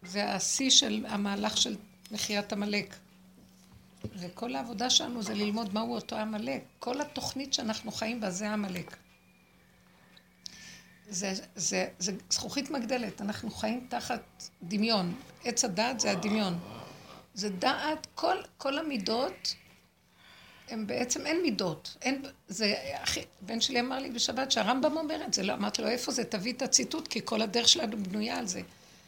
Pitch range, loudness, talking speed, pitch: 200-250 Hz, -31 LUFS, 145 wpm, 220 Hz